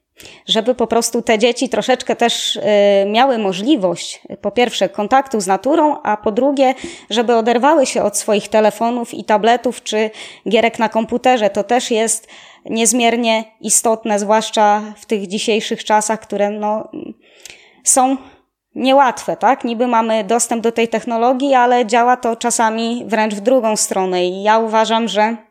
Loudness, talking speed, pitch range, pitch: -15 LUFS, 145 wpm, 215-245 Hz, 230 Hz